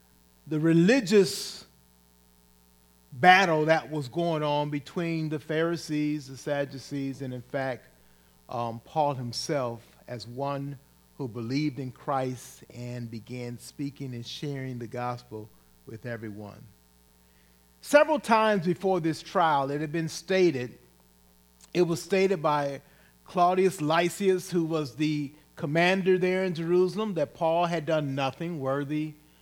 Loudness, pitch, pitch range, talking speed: -27 LUFS, 145 Hz, 120-170 Hz, 125 wpm